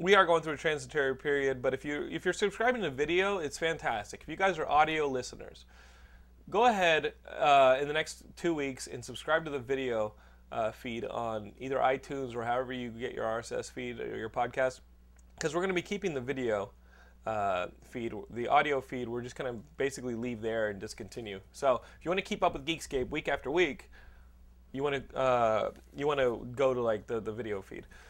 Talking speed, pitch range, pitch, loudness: 220 wpm, 110-160 Hz, 130 Hz, -32 LUFS